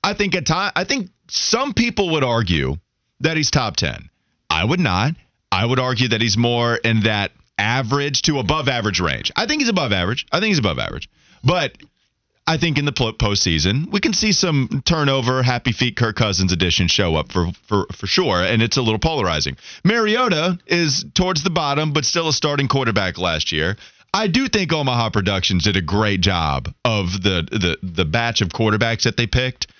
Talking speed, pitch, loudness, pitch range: 195 wpm, 120 Hz, -18 LUFS, 100-155 Hz